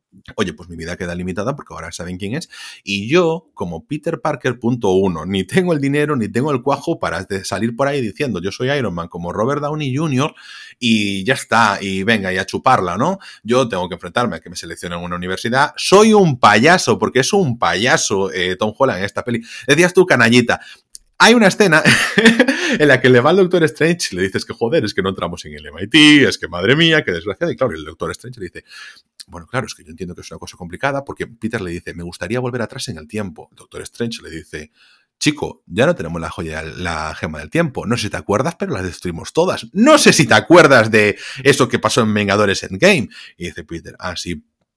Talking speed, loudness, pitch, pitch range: 235 wpm, -15 LUFS, 115 Hz, 90-145 Hz